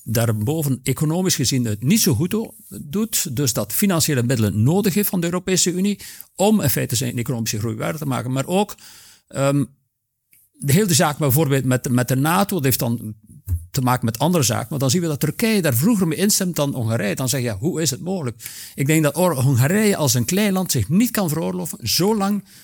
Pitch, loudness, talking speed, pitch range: 145 Hz, -19 LUFS, 210 wpm, 125-185 Hz